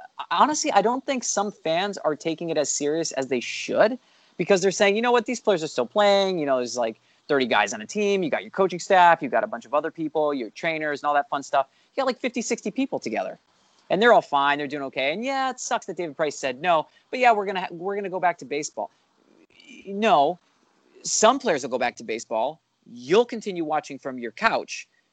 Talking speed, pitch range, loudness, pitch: 250 wpm, 150-235 Hz, -24 LUFS, 190 Hz